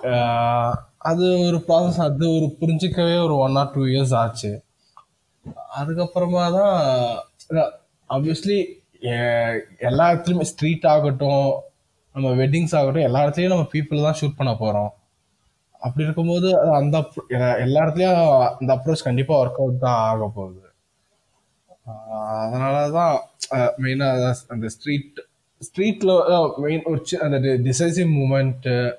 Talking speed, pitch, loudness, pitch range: 110 wpm, 145 Hz, -20 LUFS, 125-165 Hz